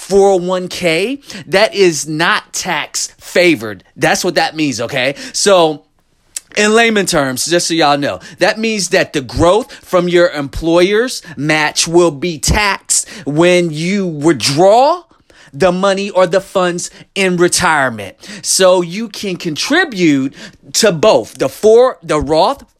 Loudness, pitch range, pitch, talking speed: -13 LUFS, 160-200 Hz, 180 Hz, 135 wpm